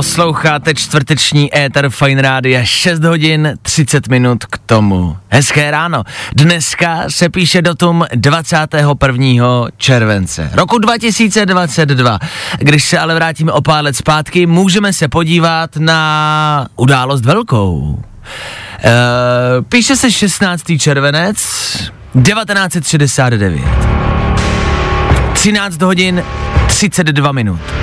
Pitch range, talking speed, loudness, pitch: 125-170 Hz, 95 wpm, -10 LUFS, 150 Hz